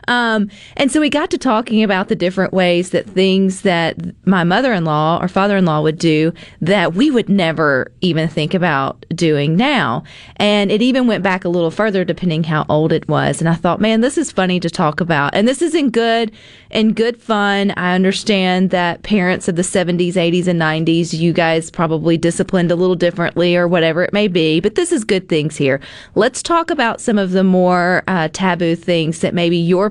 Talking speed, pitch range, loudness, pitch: 200 wpm, 170-210 Hz, -15 LUFS, 180 Hz